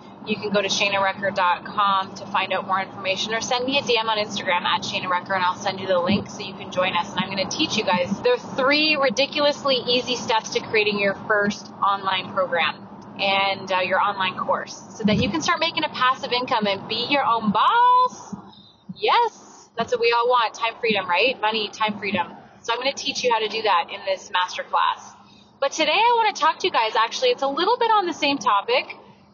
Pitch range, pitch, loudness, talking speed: 195-275 Hz, 220 Hz, -21 LUFS, 225 wpm